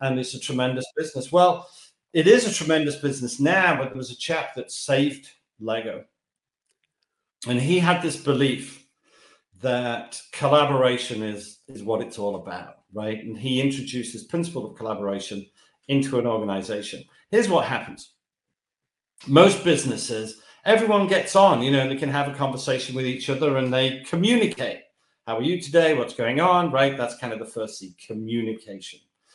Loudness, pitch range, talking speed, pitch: -23 LUFS, 115-150 Hz, 165 wpm, 130 Hz